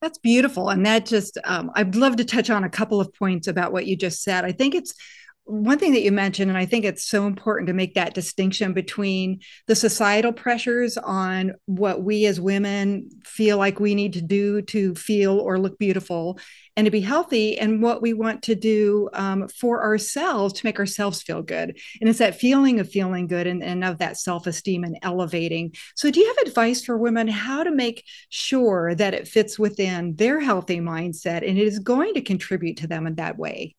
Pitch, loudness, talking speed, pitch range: 205 Hz, -22 LUFS, 215 wpm, 185-230 Hz